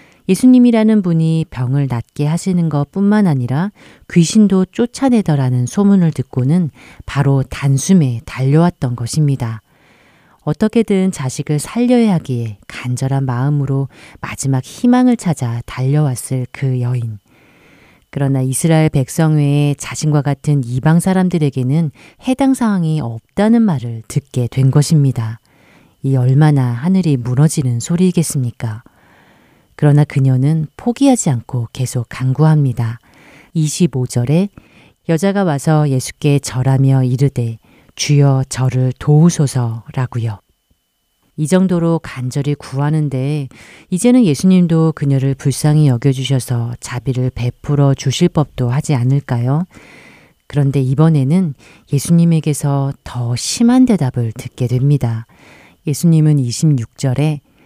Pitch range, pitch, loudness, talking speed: 125-160 Hz, 140 Hz, -15 LUFS, 275 characters per minute